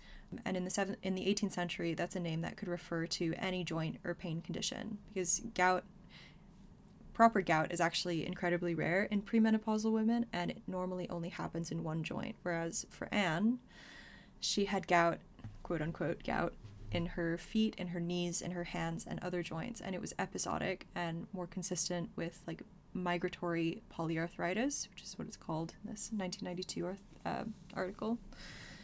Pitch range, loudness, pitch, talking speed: 170-200 Hz, -37 LUFS, 180 Hz, 170 wpm